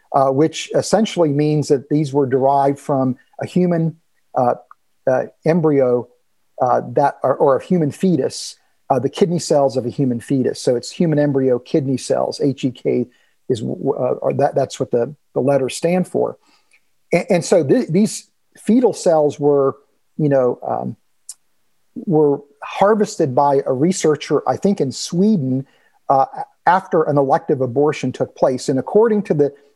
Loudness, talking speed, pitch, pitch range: -18 LUFS, 160 wpm, 145 Hz, 135-175 Hz